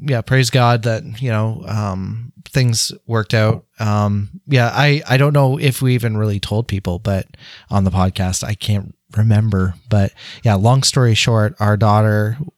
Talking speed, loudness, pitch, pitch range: 170 wpm, -16 LUFS, 110 Hz, 105-125 Hz